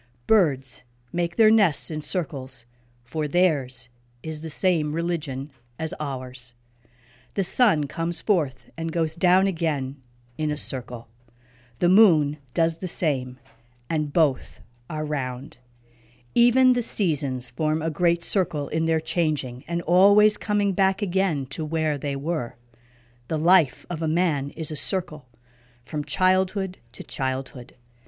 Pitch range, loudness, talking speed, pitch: 125-175 Hz, -24 LUFS, 140 wpm, 150 Hz